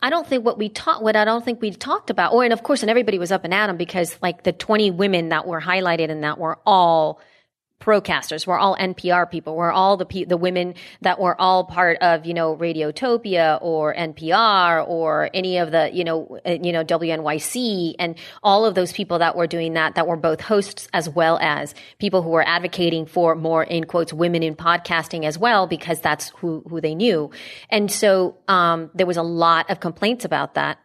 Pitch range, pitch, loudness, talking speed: 165-195 Hz, 175 Hz, -20 LUFS, 220 wpm